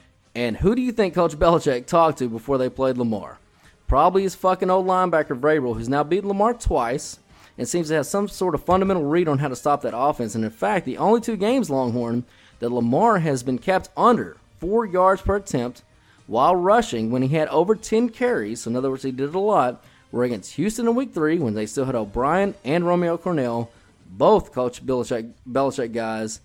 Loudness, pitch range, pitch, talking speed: -22 LUFS, 120-190 Hz, 145 Hz, 210 wpm